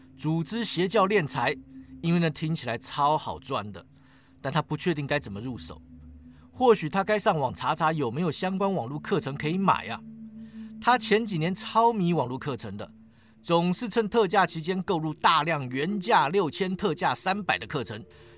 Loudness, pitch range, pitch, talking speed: -26 LUFS, 135-200 Hz, 165 Hz, 260 characters per minute